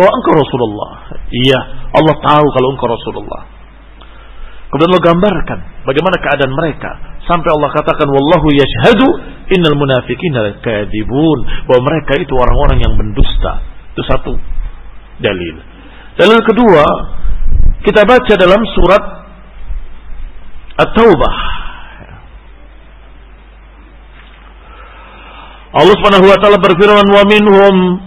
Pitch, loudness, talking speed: 140 Hz, -10 LUFS, 100 wpm